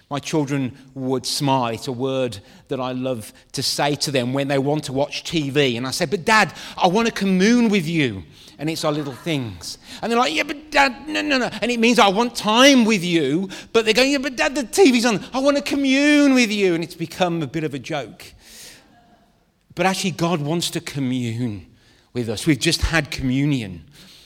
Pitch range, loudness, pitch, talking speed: 135-225 Hz, -19 LUFS, 160 Hz, 220 wpm